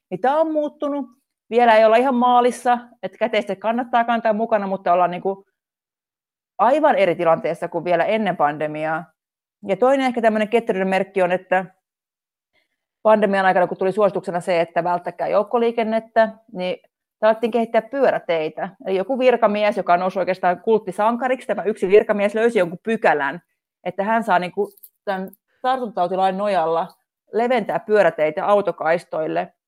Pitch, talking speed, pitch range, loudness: 205 Hz, 140 wpm, 180-230 Hz, -20 LUFS